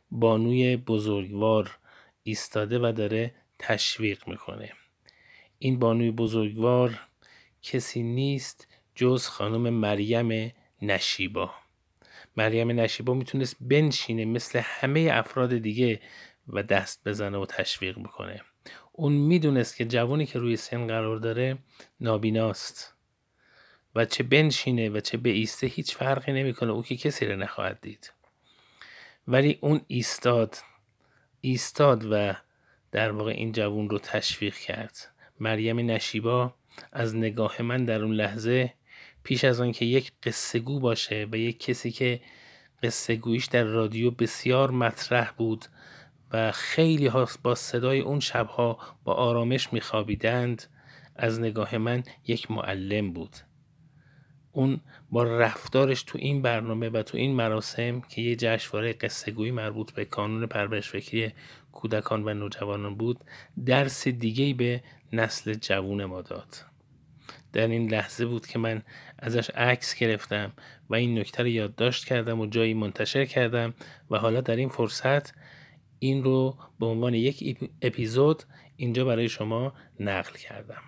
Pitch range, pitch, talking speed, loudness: 110-130 Hz, 115 Hz, 130 wpm, -27 LUFS